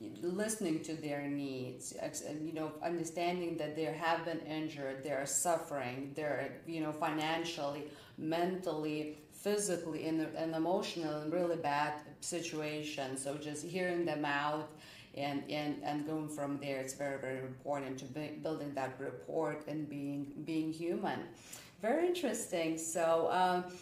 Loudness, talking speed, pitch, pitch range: -38 LUFS, 145 wpm, 155 Hz, 145-165 Hz